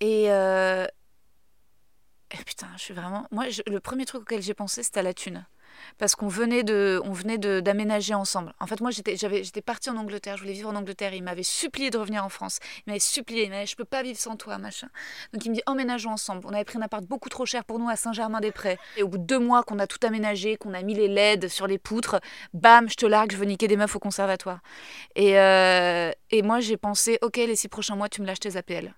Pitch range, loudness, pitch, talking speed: 195-230 Hz, -25 LUFS, 210 Hz, 260 wpm